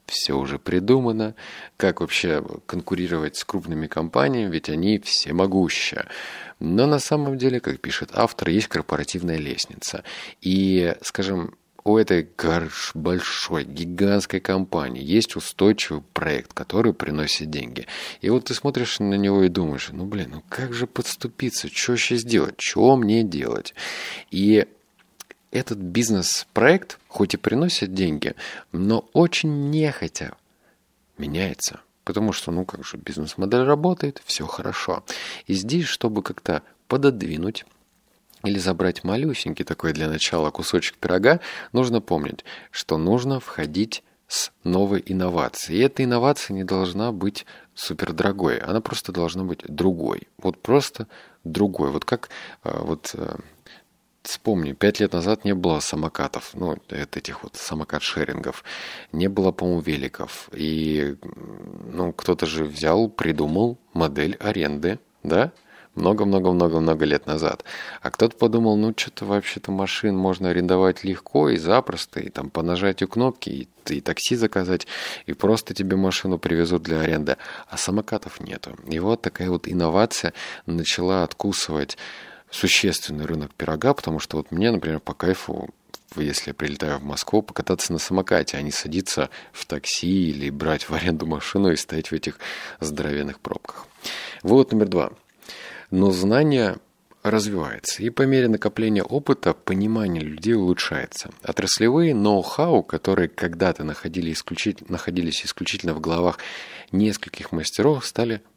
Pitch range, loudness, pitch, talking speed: 80-110 Hz, -23 LUFS, 95 Hz, 135 wpm